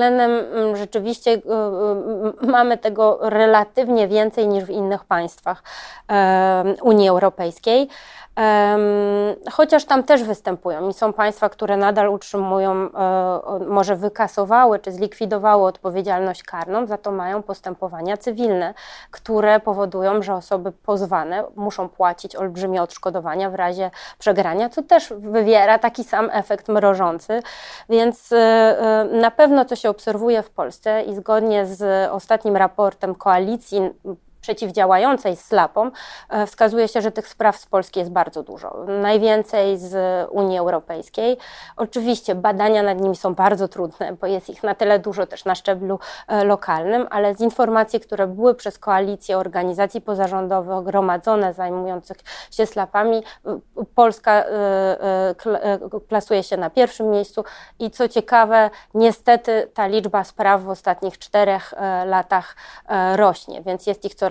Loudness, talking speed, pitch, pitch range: -19 LUFS, 125 wpm, 205 Hz, 190-220 Hz